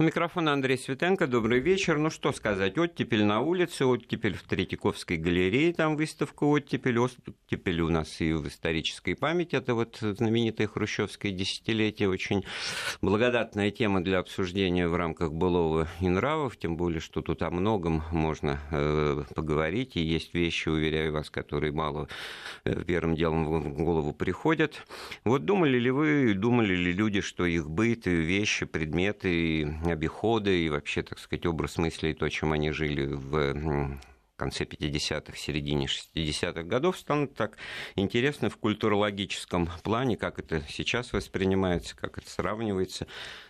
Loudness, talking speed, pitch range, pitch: -28 LUFS, 145 wpm, 80-115 Hz, 95 Hz